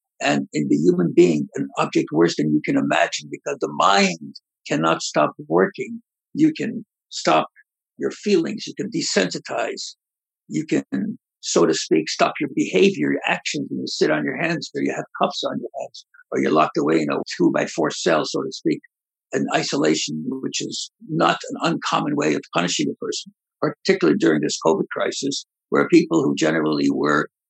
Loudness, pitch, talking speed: -21 LUFS, 275 Hz, 185 wpm